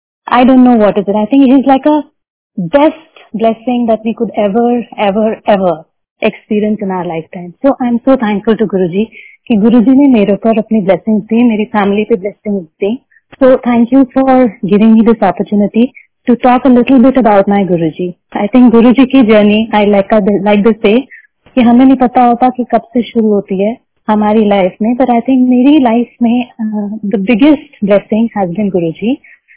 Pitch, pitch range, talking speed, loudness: 225 Hz, 205-250 Hz, 180 wpm, -10 LUFS